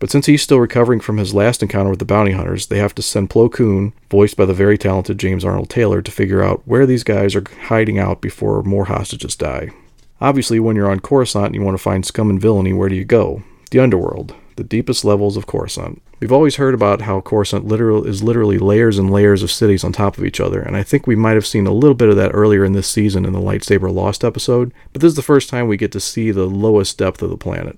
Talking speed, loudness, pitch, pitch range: 260 wpm, -15 LUFS, 105 Hz, 100-115 Hz